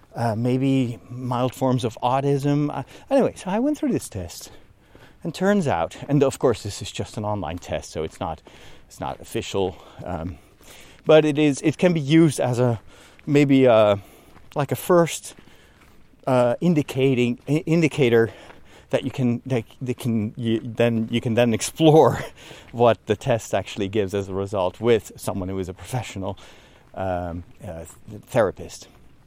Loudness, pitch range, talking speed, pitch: -22 LUFS, 105-145 Hz, 165 wpm, 120 Hz